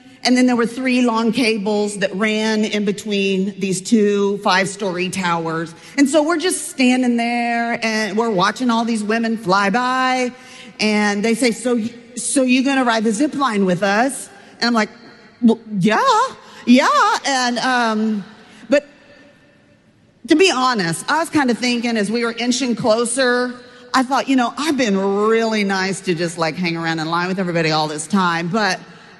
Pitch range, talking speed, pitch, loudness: 200-250 Hz, 175 wpm, 225 Hz, -17 LUFS